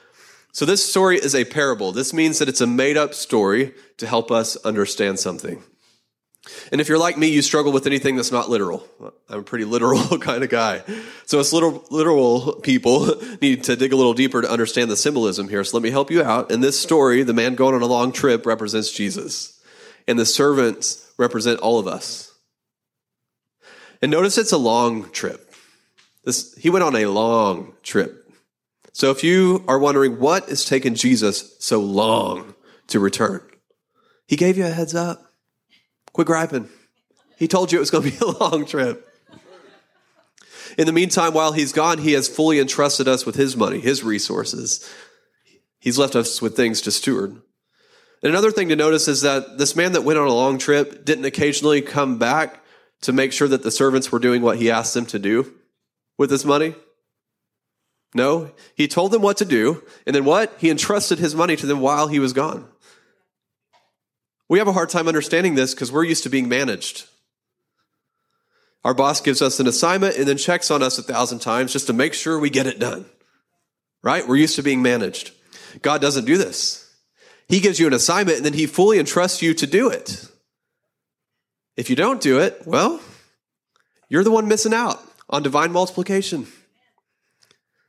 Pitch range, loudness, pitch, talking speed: 125-165 Hz, -19 LUFS, 145 Hz, 185 wpm